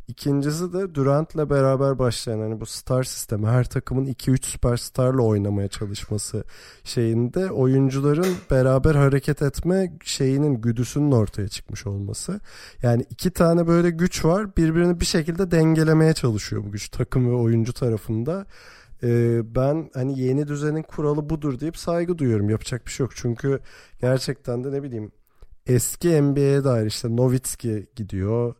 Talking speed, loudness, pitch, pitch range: 140 wpm, -22 LUFS, 130 Hz, 115-150 Hz